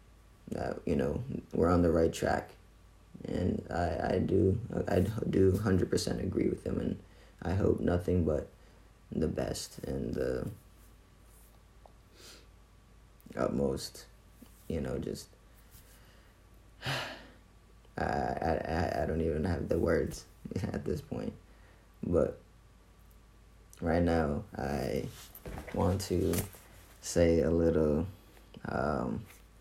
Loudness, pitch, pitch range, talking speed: -33 LUFS, 95 Hz, 85-105 Hz, 105 wpm